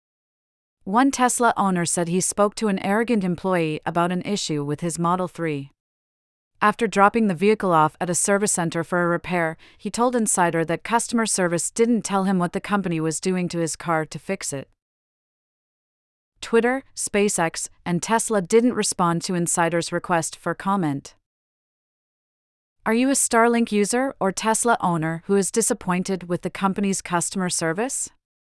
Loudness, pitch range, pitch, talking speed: -22 LUFS, 170-210 Hz, 185 Hz, 160 wpm